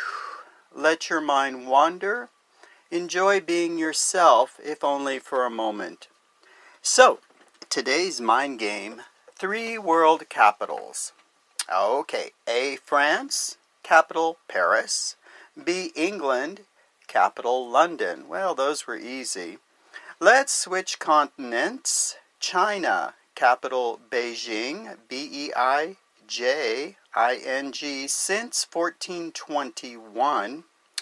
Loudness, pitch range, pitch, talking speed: -24 LUFS, 135-220 Hz, 165 Hz, 90 wpm